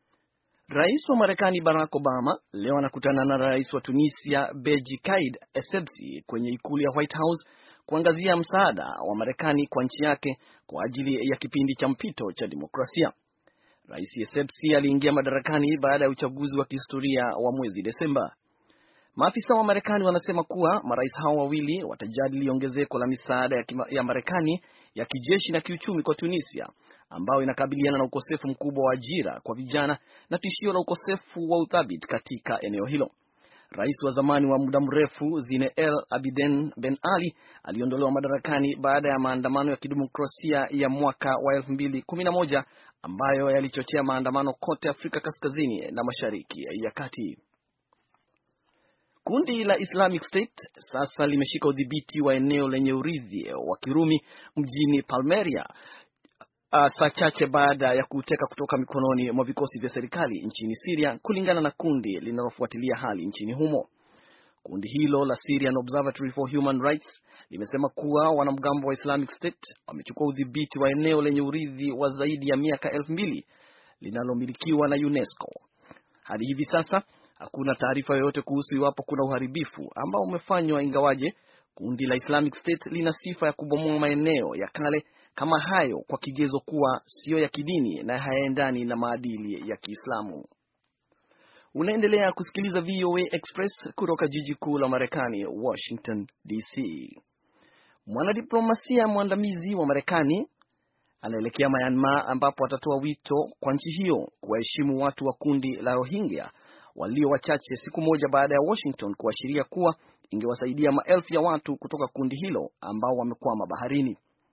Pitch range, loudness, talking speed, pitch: 135-155 Hz, -27 LUFS, 135 wpm, 140 Hz